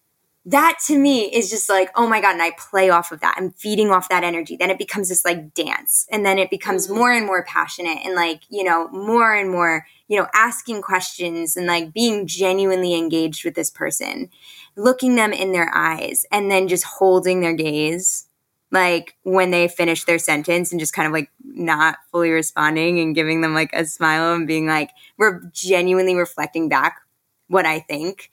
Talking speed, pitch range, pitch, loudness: 200 wpm, 165-195 Hz, 180 Hz, -18 LUFS